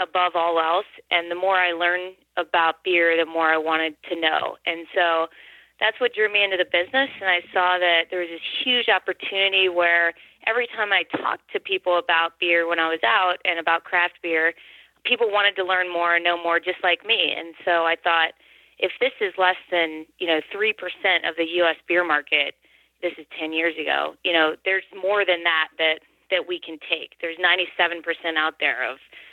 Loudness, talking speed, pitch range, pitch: -21 LUFS, 215 wpm, 165-185 Hz, 175 Hz